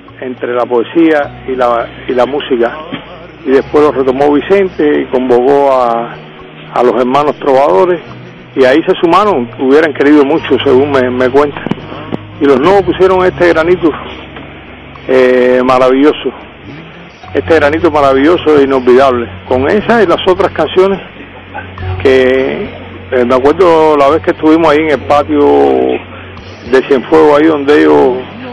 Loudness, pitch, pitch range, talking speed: -9 LUFS, 135 Hz, 125-155 Hz, 140 wpm